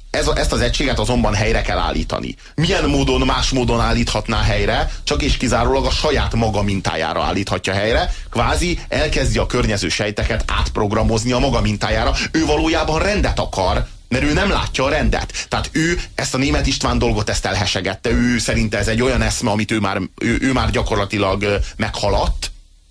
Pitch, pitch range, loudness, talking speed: 110 Hz, 100-125 Hz, -18 LUFS, 170 wpm